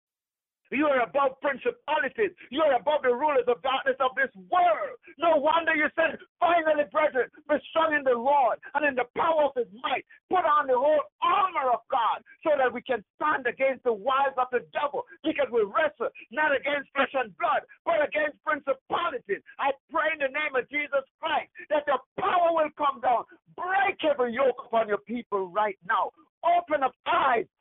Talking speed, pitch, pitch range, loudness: 185 wpm, 295 Hz, 260-325 Hz, -26 LUFS